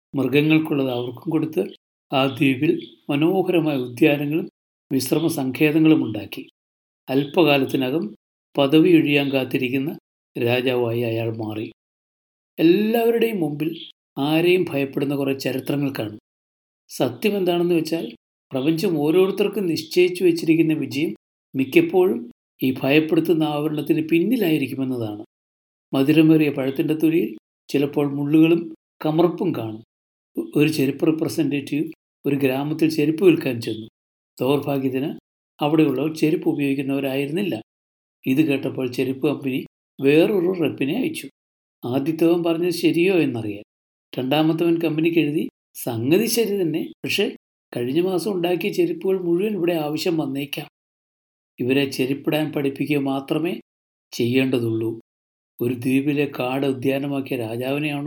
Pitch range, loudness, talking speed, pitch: 130-160 Hz, -21 LUFS, 95 wpm, 145 Hz